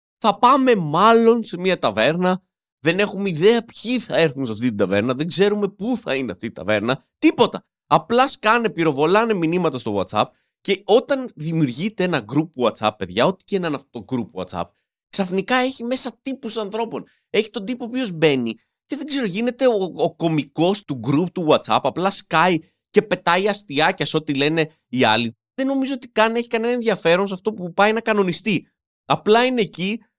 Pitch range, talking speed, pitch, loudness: 155-225 Hz, 185 wpm, 190 Hz, -20 LUFS